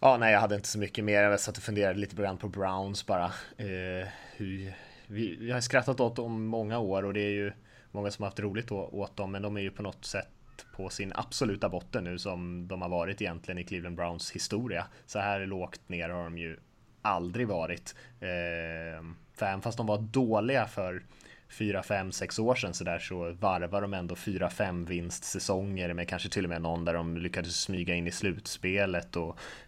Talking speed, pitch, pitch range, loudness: 215 wpm, 100 Hz, 90-105 Hz, -33 LUFS